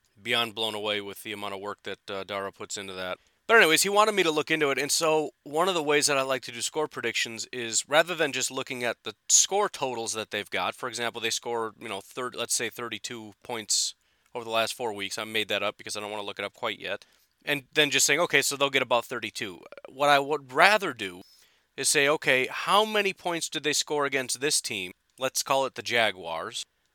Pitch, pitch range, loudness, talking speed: 125 Hz, 110-145 Hz, -26 LUFS, 245 wpm